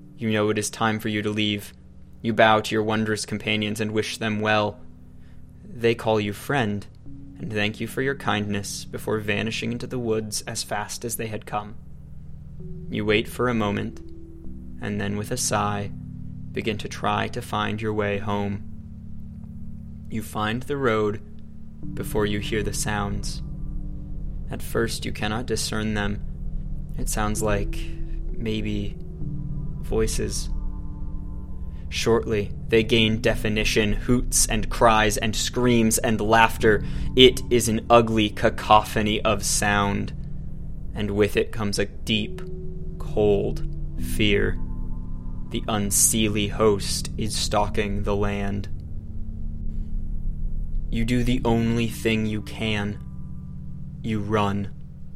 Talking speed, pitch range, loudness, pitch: 130 wpm, 85-110 Hz, -24 LUFS, 105 Hz